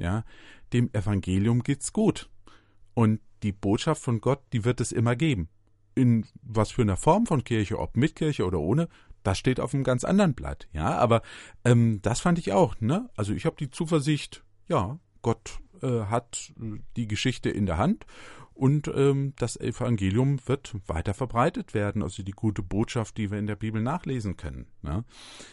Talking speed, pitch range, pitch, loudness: 180 wpm, 105-130 Hz, 115 Hz, -27 LUFS